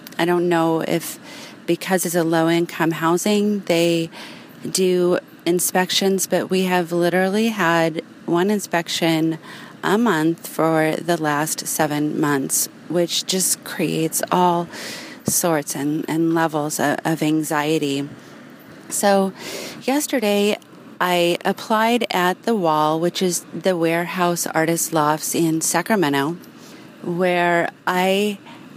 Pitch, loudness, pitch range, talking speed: 175 Hz, -20 LUFS, 160-190 Hz, 115 wpm